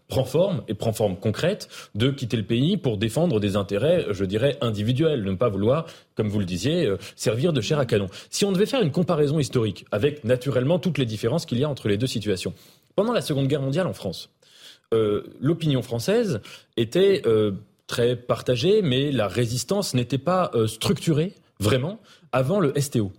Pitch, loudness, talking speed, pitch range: 125 Hz, -24 LUFS, 195 wpm, 110-160 Hz